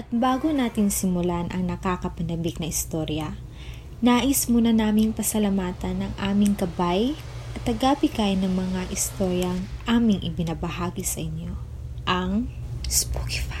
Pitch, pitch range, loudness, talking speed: 185 Hz, 170-220 Hz, -24 LUFS, 115 wpm